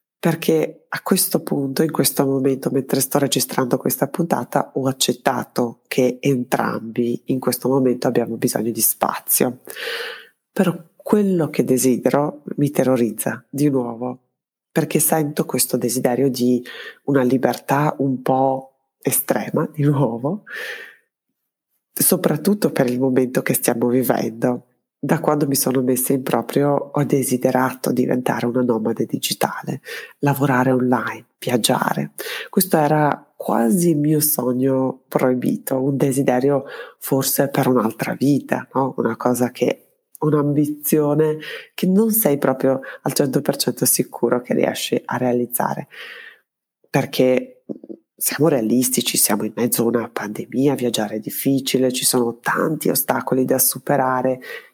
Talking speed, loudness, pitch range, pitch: 125 wpm, -19 LUFS, 125-145 Hz, 135 Hz